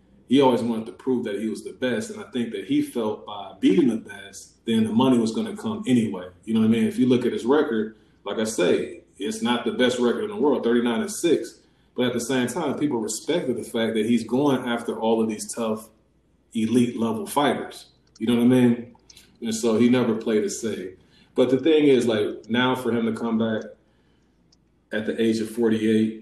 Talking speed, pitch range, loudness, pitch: 230 wpm, 110-125 Hz, -23 LUFS, 120 Hz